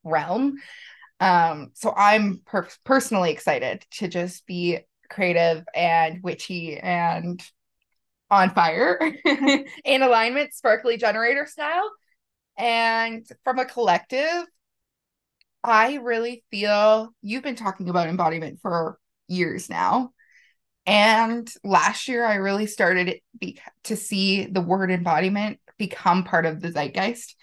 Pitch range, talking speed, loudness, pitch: 175-235 Hz, 115 wpm, -22 LUFS, 210 Hz